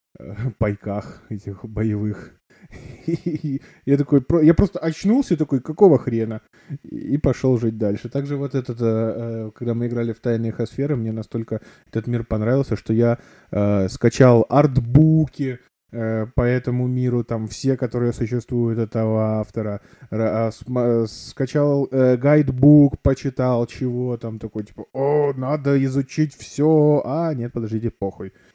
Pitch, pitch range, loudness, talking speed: 120 Hz, 110-140 Hz, -20 LUFS, 120 wpm